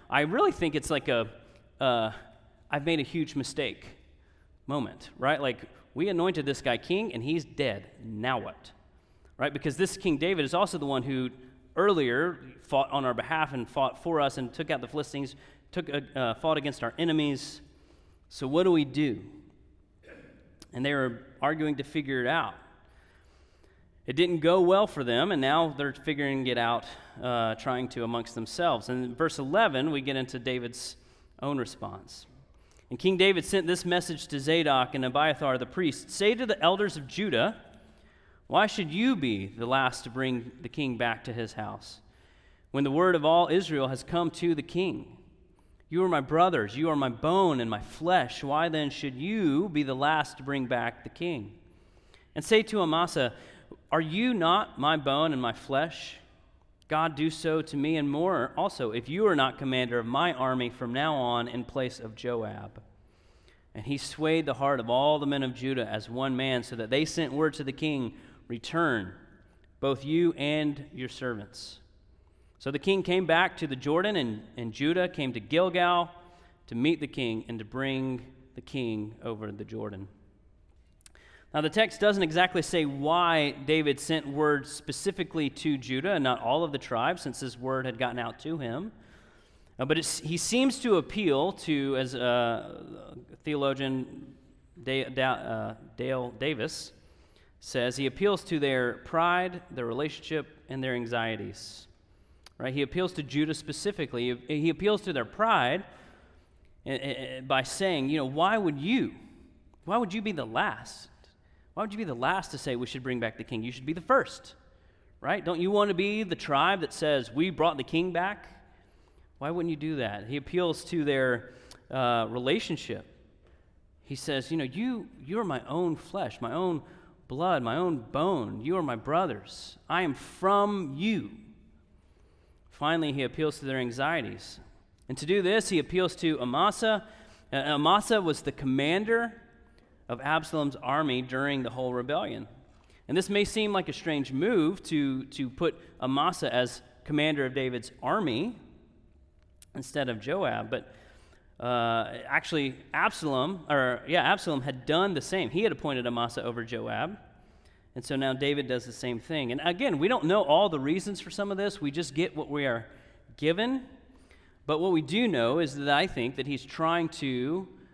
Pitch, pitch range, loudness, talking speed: 140 Hz, 120-165 Hz, -29 LUFS, 180 wpm